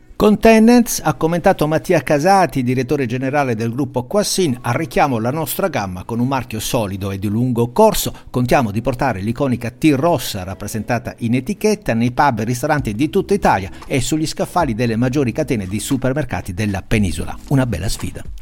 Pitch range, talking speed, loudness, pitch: 115-160 Hz, 170 wpm, -17 LUFS, 130 Hz